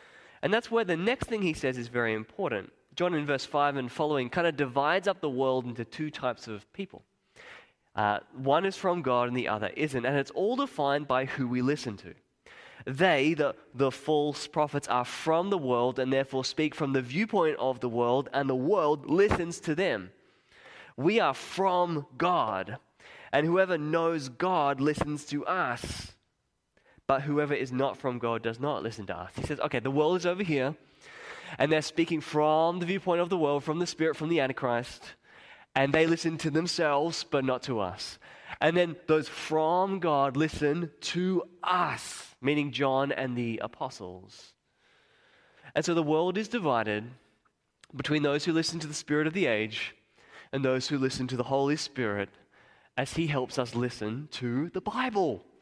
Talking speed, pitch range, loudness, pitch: 180 wpm, 130-165 Hz, -29 LUFS, 145 Hz